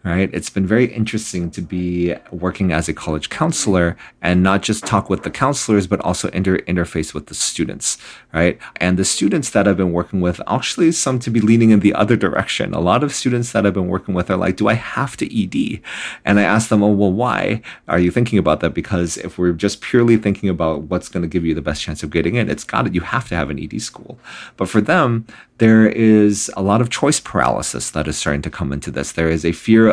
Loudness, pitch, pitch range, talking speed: -17 LUFS, 95 Hz, 85-110 Hz, 245 wpm